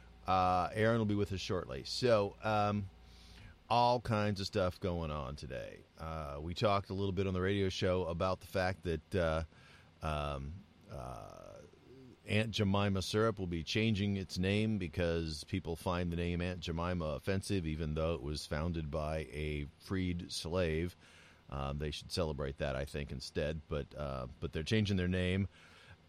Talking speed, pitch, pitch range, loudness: 170 wpm, 85 Hz, 80-100 Hz, -36 LUFS